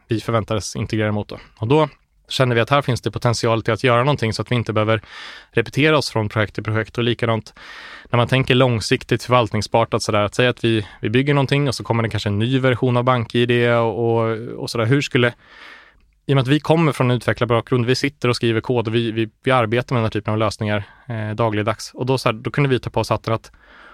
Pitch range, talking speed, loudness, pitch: 110-130 Hz, 245 wpm, -19 LUFS, 120 Hz